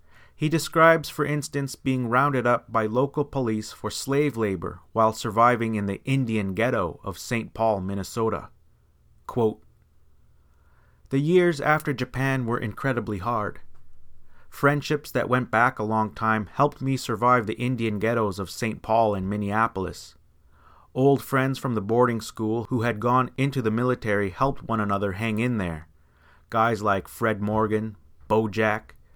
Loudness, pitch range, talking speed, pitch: -25 LUFS, 100-130 Hz, 150 wpm, 115 Hz